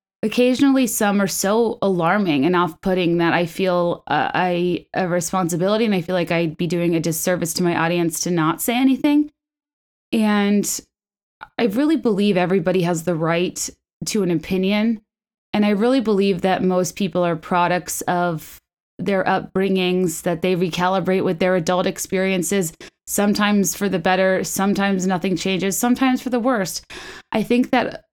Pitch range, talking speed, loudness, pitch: 175-210 Hz, 160 wpm, -20 LUFS, 190 Hz